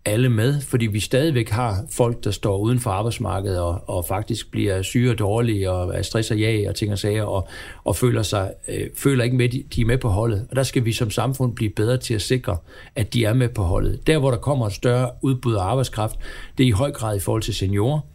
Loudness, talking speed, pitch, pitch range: -22 LUFS, 250 wpm, 115 Hz, 105-125 Hz